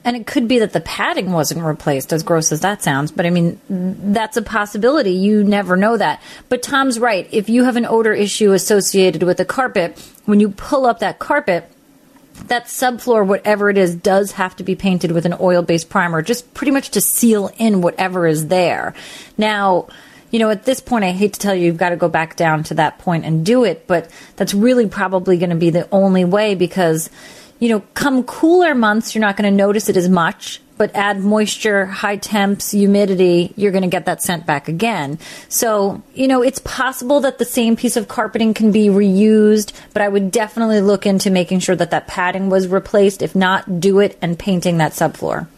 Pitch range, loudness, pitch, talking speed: 180-225 Hz, -16 LUFS, 200 Hz, 215 wpm